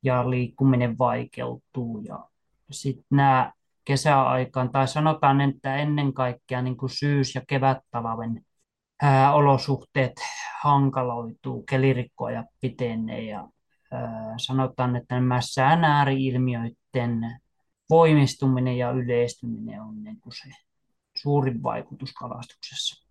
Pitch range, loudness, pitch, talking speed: 125-140 Hz, -24 LUFS, 130 Hz, 95 wpm